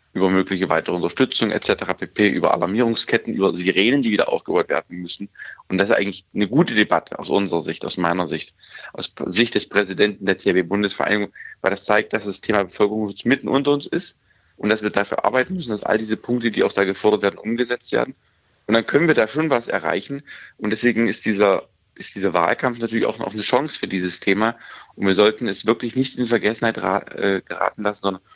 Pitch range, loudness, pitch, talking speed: 100-120 Hz, -21 LUFS, 105 Hz, 205 wpm